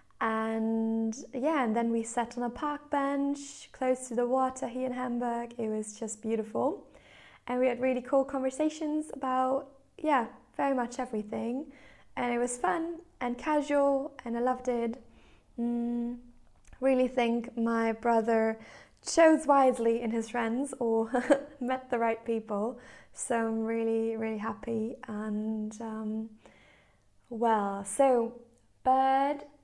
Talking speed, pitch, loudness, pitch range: 135 wpm, 245 Hz, -30 LUFS, 225-265 Hz